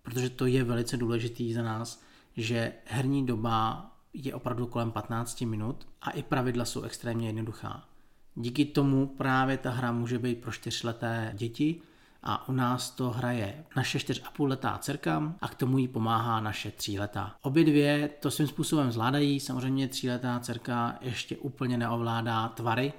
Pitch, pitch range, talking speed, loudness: 125 Hz, 115-135 Hz, 165 wpm, -31 LUFS